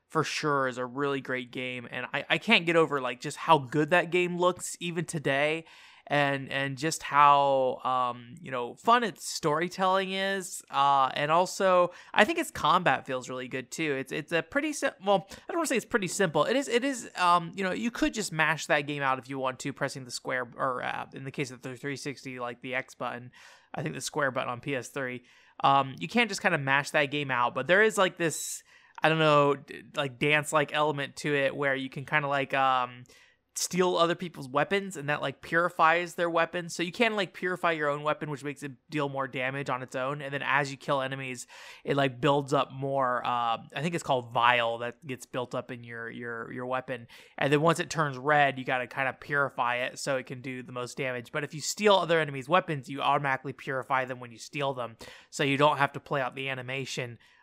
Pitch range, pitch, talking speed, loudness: 130-170 Hz, 145 Hz, 235 wpm, -28 LUFS